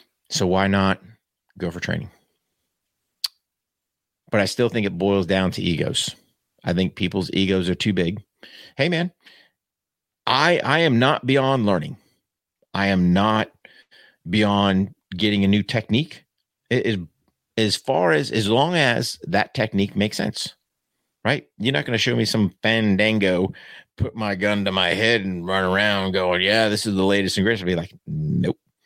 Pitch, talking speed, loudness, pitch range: 100 Hz, 165 wpm, -21 LUFS, 95-110 Hz